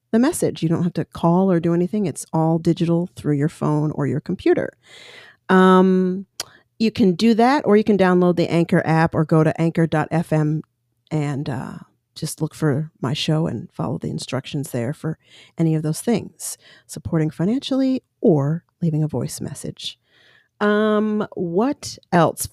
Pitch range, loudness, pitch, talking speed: 155-195 Hz, -20 LUFS, 165 Hz, 165 wpm